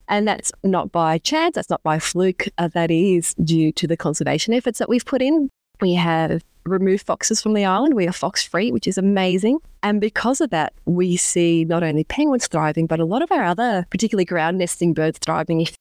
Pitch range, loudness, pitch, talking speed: 165-215 Hz, -20 LUFS, 180 Hz, 215 wpm